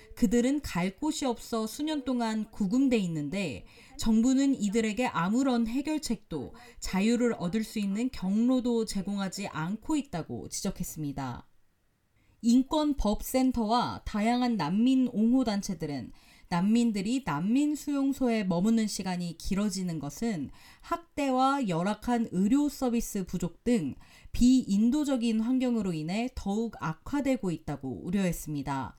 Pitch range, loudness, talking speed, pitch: 180-250 Hz, -29 LUFS, 285 characters per minute, 220 Hz